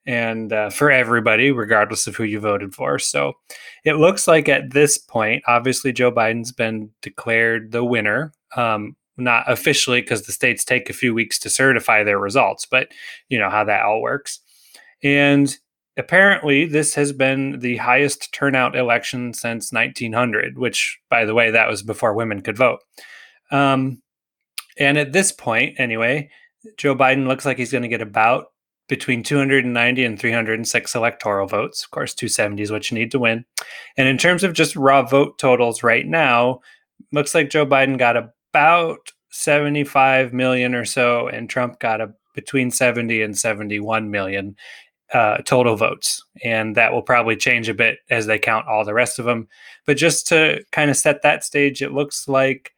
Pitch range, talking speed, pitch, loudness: 115-140 Hz, 175 wpm, 125 Hz, -18 LUFS